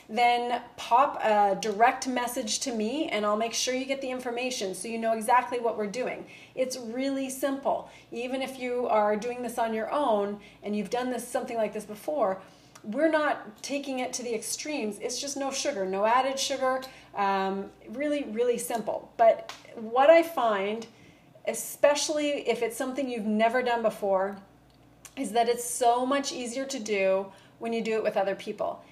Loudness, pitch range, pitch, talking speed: -28 LUFS, 215-265 Hz, 240 Hz, 180 wpm